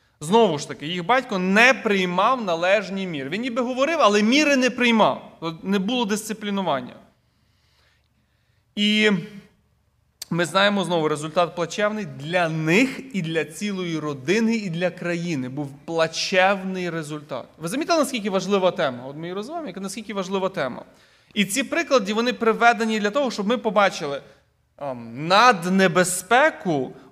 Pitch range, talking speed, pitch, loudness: 170-225 Hz, 130 wpm, 195 Hz, -21 LUFS